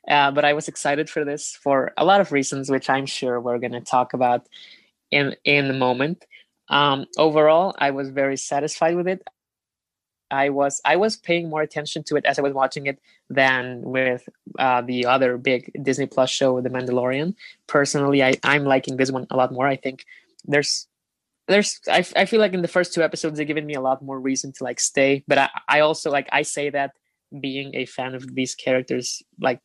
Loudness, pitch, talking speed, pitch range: -21 LUFS, 140 Hz, 215 wpm, 130-150 Hz